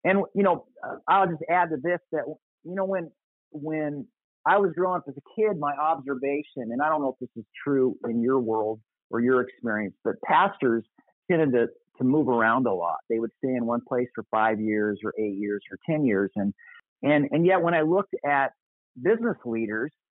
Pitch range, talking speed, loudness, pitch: 115-165 Hz, 210 wpm, -26 LUFS, 140 Hz